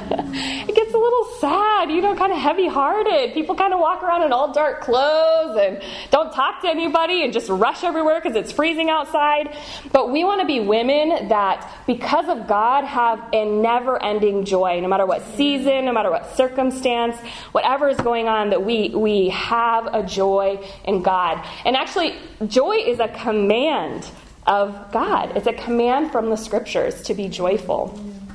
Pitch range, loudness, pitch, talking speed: 215-320 Hz, -19 LUFS, 260 Hz, 180 wpm